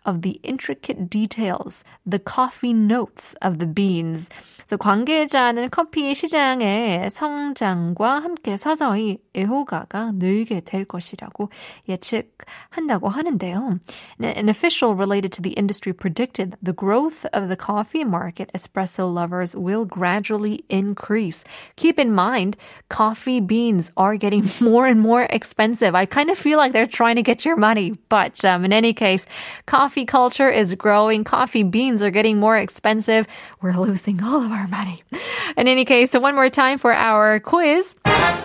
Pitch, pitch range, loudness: 215 Hz, 195-255 Hz, -19 LUFS